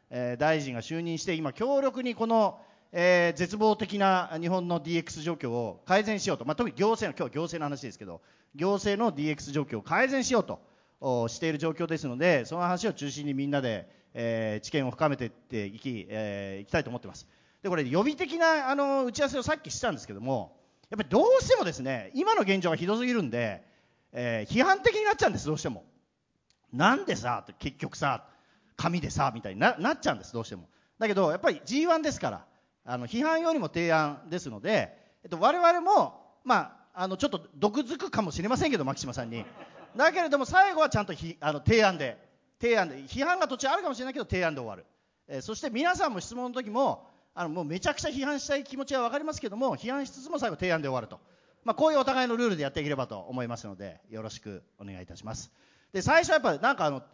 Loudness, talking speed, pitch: -28 LUFS, 425 characters per minute, 180 Hz